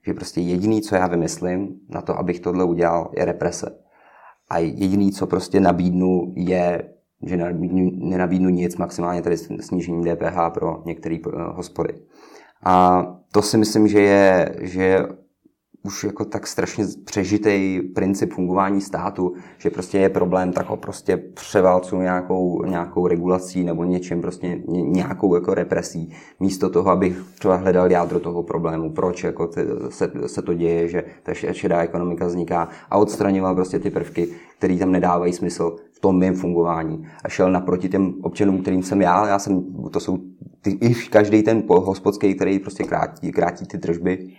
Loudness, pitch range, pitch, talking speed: -21 LUFS, 85-95 Hz, 90 Hz, 155 wpm